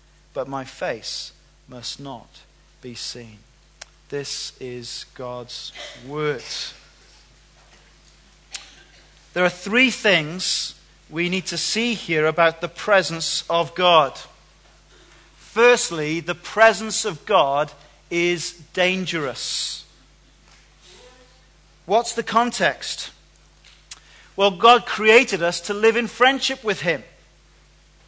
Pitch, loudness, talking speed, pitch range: 170 Hz, -20 LUFS, 95 wpm, 150-210 Hz